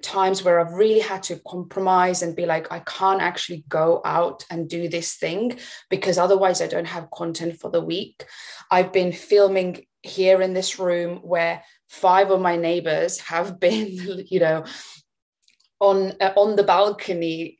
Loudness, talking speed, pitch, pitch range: -21 LUFS, 165 wpm, 180 Hz, 170-190 Hz